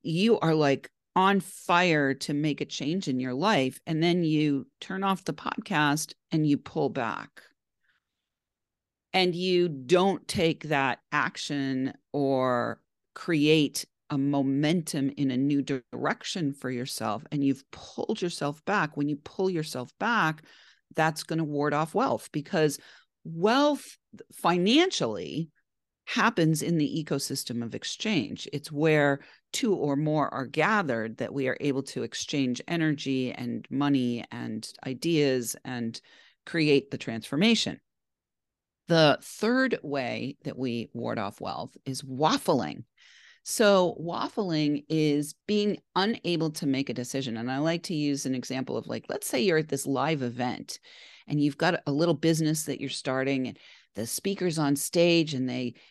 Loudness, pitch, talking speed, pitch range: -28 LUFS, 150 Hz, 145 wpm, 135-170 Hz